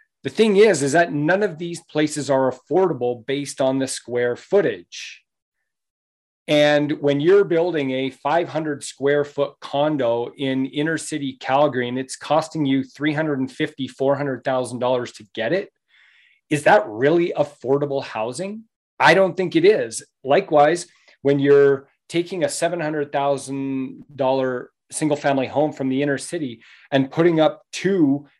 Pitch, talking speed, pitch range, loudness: 145 Hz, 135 wpm, 135-165 Hz, -20 LUFS